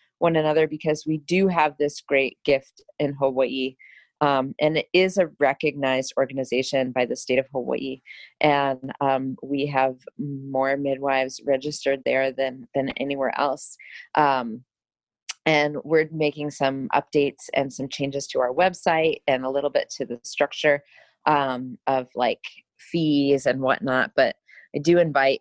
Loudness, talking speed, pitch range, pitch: -23 LUFS, 150 wpm, 130-150 Hz, 140 Hz